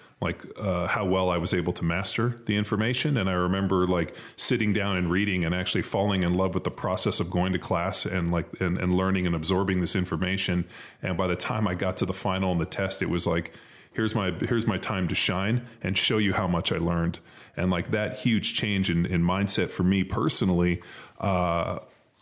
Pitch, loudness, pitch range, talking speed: 95 Hz, -26 LUFS, 90-105 Hz, 220 wpm